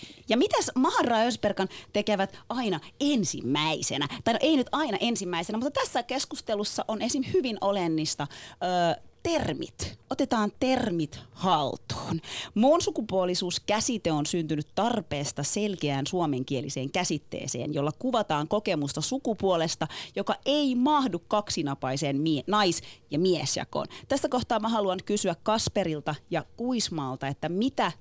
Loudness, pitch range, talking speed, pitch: -28 LUFS, 155-235 Hz, 120 wpm, 195 Hz